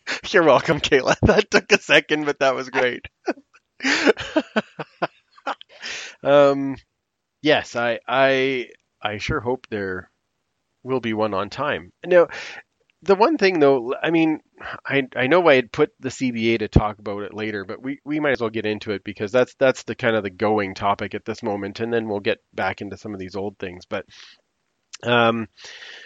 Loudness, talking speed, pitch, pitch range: -21 LUFS, 180 wpm, 115 Hz, 105-140 Hz